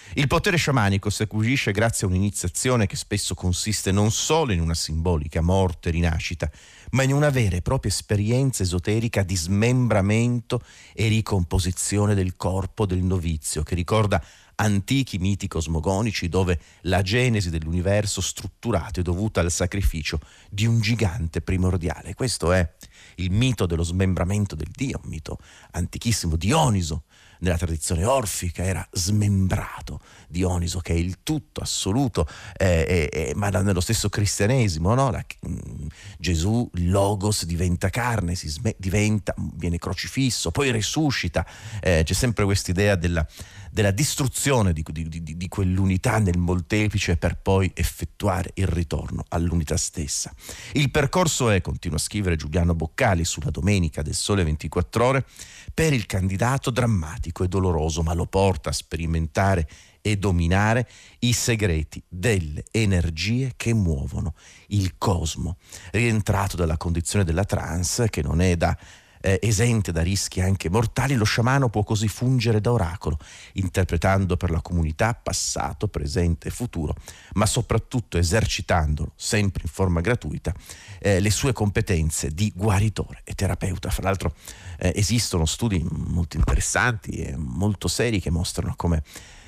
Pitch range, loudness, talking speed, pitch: 85-110 Hz, -24 LUFS, 140 wpm, 95 Hz